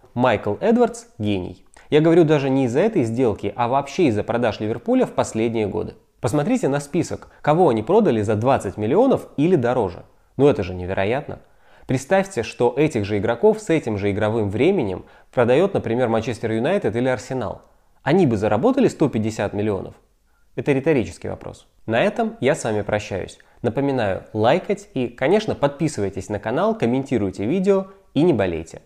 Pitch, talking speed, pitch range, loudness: 125 Hz, 155 wpm, 105-155 Hz, -20 LUFS